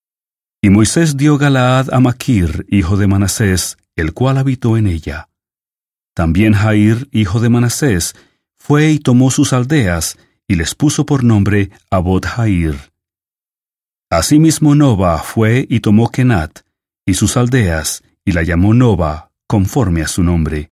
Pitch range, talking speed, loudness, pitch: 90-130 Hz, 135 wpm, -13 LUFS, 105 Hz